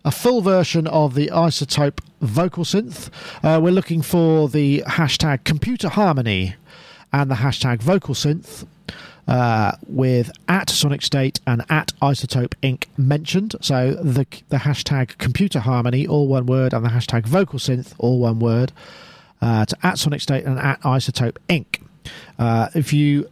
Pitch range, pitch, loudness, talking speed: 130-160 Hz, 140 Hz, -19 LUFS, 155 wpm